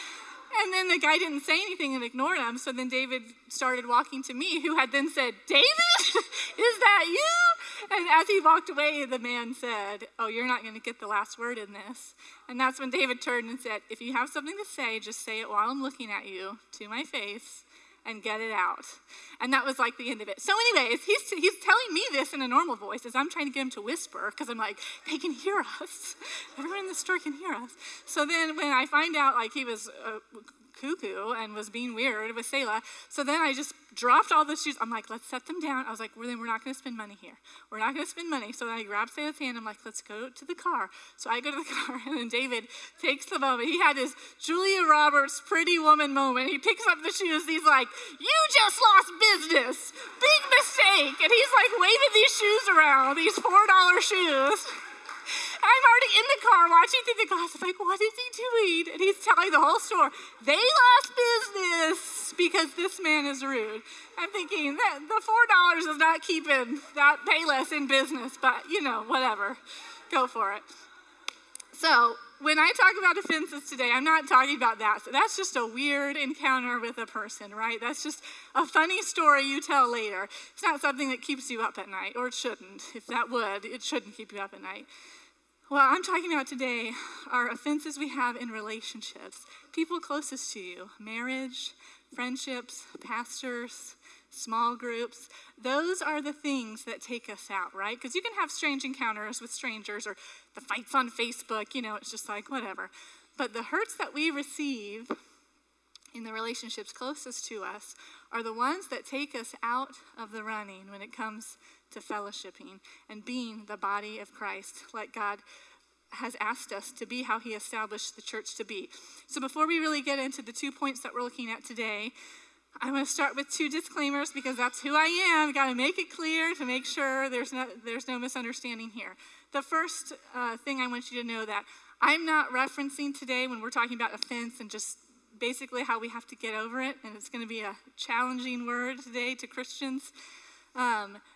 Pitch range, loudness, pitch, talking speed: 235-325 Hz, -27 LUFS, 270 Hz, 210 wpm